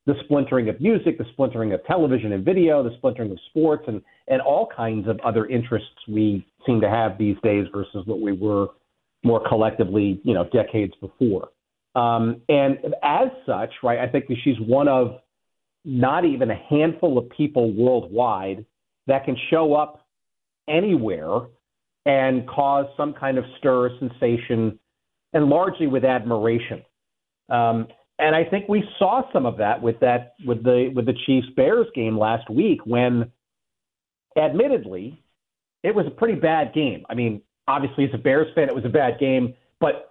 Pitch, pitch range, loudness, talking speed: 125 Hz, 115-145 Hz, -22 LUFS, 170 wpm